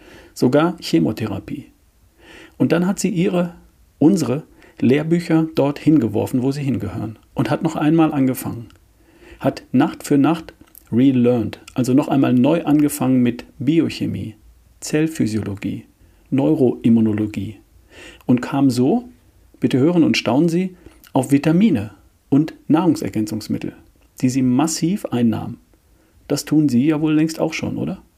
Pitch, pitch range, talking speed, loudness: 130 Hz, 110-155 Hz, 125 wpm, -18 LUFS